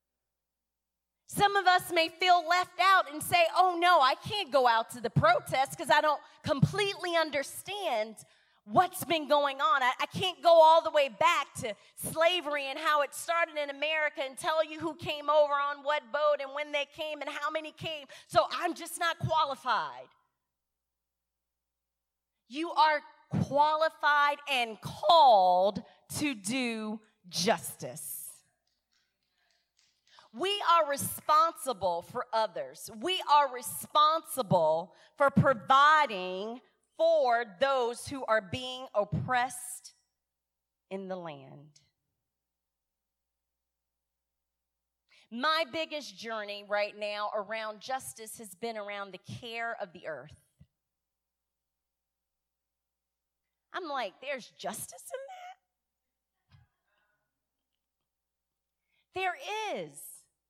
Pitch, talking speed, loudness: 250 Hz, 115 wpm, -29 LUFS